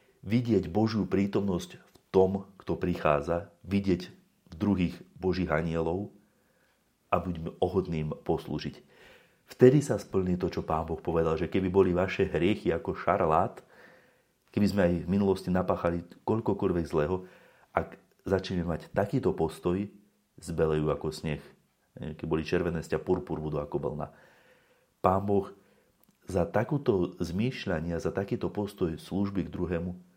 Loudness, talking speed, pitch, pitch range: -30 LUFS, 130 wpm, 90 Hz, 85-100 Hz